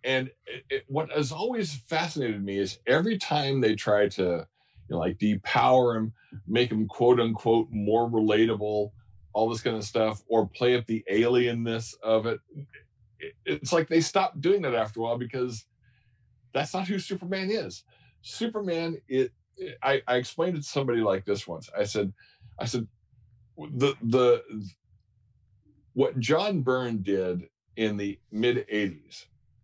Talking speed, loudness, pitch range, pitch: 160 wpm, -27 LUFS, 110-140 Hz, 120 Hz